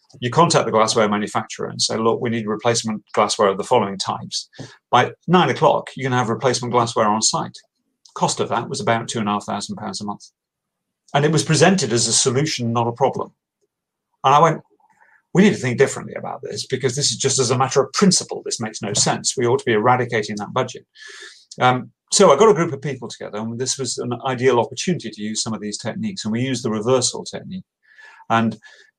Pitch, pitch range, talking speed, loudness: 130 Hz, 115-160 Hz, 220 wpm, -19 LUFS